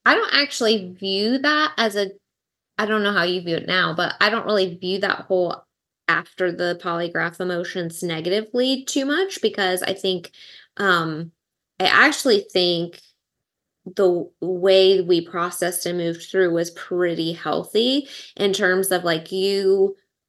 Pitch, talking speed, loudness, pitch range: 185 Hz, 150 wpm, -21 LUFS, 175-205 Hz